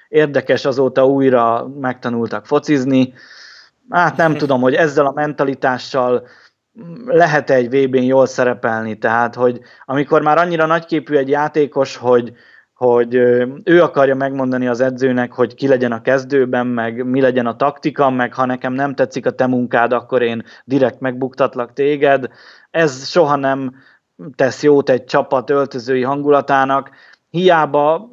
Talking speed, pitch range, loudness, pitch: 140 wpm, 125-145 Hz, -15 LUFS, 135 Hz